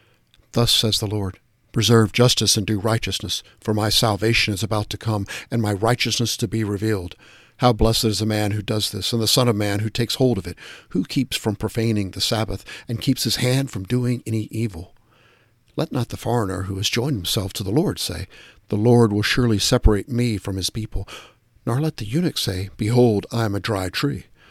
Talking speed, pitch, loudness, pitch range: 210 wpm, 110 Hz, -21 LUFS, 105-120 Hz